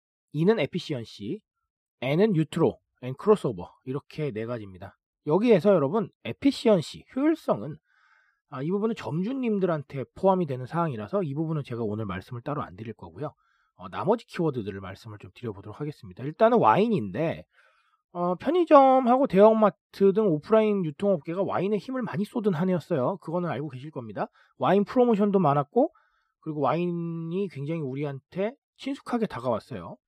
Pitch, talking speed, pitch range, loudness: 170 Hz, 375 characters per minute, 140-215 Hz, -26 LUFS